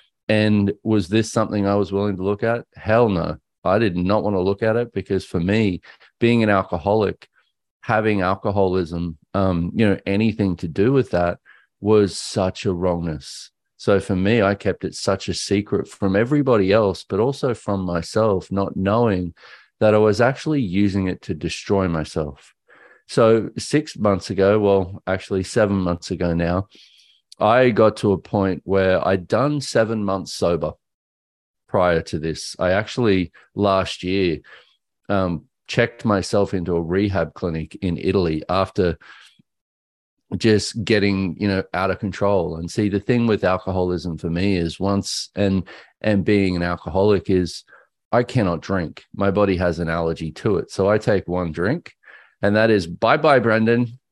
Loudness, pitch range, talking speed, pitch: -20 LUFS, 90-105 Hz, 165 wpm, 100 Hz